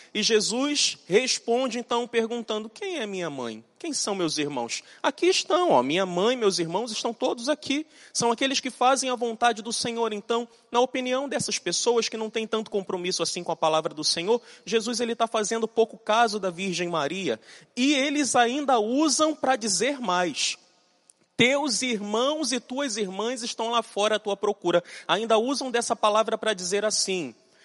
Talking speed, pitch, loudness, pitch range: 175 wpm, 230 Hz, -25 LUFS, 205-255 Hz